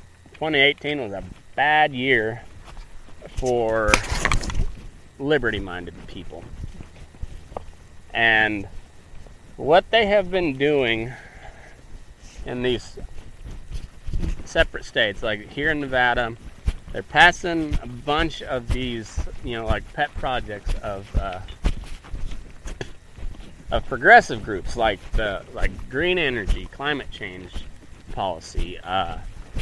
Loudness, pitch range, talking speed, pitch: -22 LUFS, 90-130 Hz, 95 wpm, 110 Hz